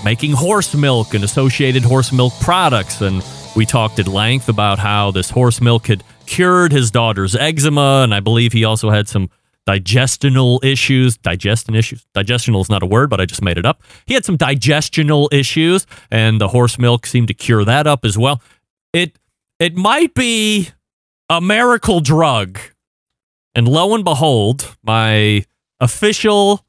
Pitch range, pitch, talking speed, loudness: 110-150 Hz, 125 Hz, 165 wpm, -14 LUFS